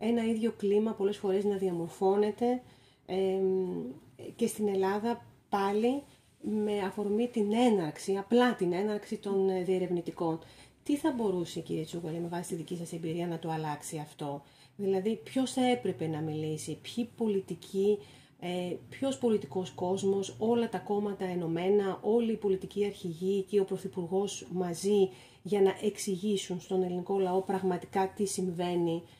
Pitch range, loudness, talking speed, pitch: 175-210 Hz, -32 LUFS, 145 wpm, 190 Hz